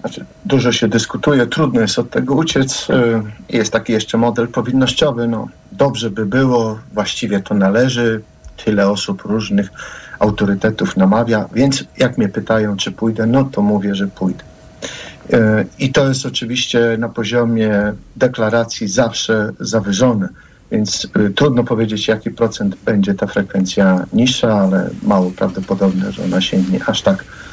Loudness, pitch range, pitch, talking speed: -16 LUFS, 100-120 Hz, 110 Hz, 135 wpm